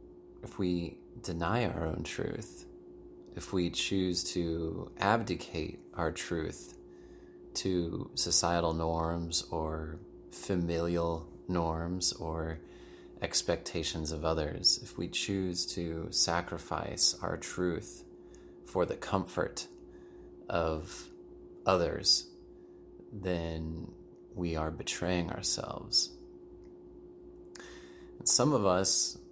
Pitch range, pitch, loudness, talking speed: 80-95 Hz, 85 Hz, -32 LUFS, 90 wpm